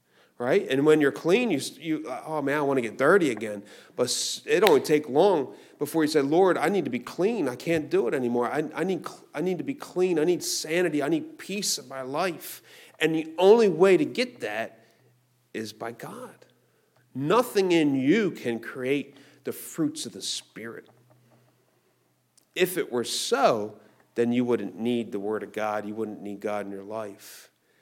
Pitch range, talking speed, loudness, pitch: 115-180 Hz, 195 wpm, -26 LUFS, 140 Hz